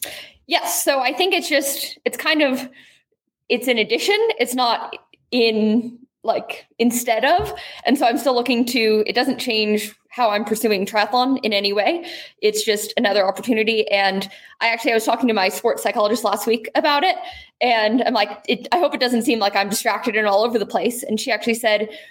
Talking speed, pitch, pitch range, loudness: 200 wpm, 230 Hz, 215-260 Hz, -19 LUFS